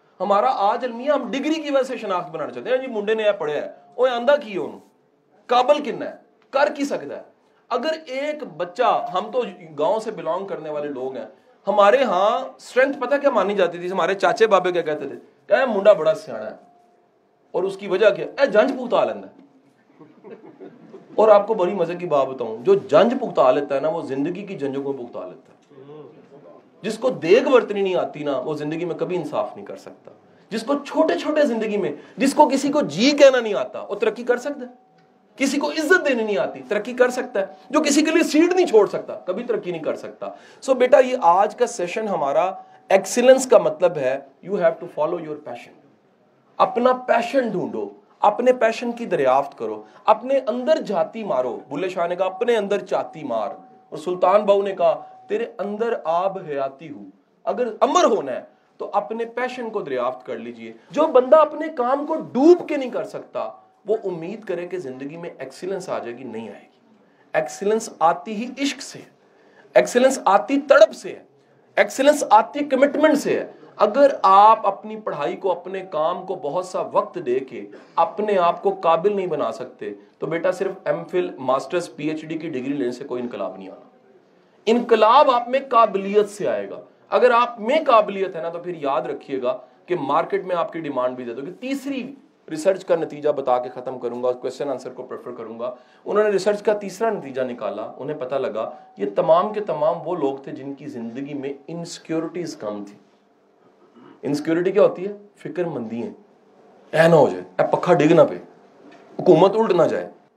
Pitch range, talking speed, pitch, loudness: 170-260 Hz, 200 wpm, 205 Hz, -20 LUFS